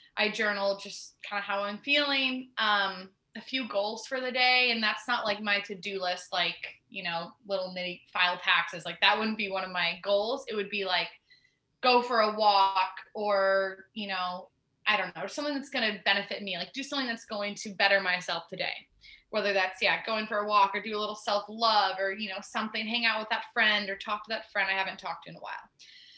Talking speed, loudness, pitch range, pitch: 225 wpm, -29 LUFS, 190-220 Hz, 205 Hz